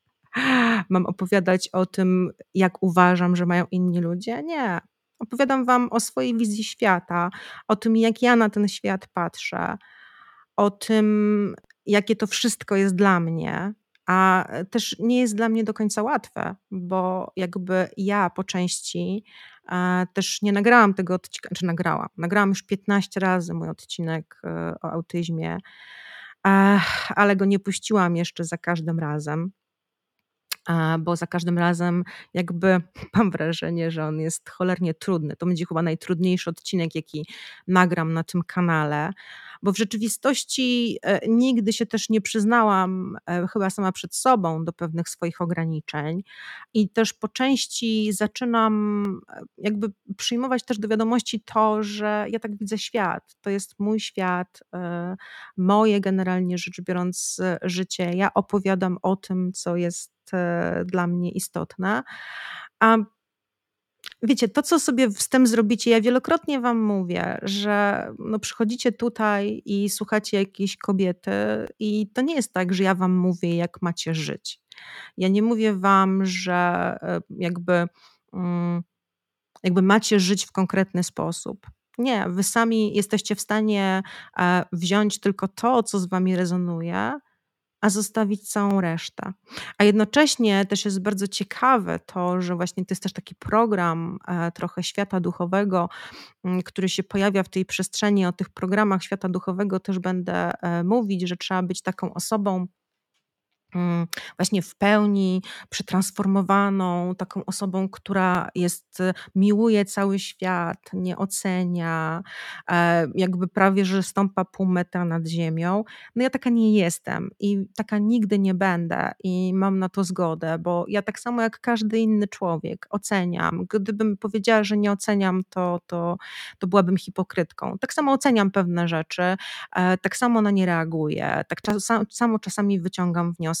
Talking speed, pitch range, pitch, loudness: 145 wpm, 180-215 Hz, 190 Hz, -23 LUFS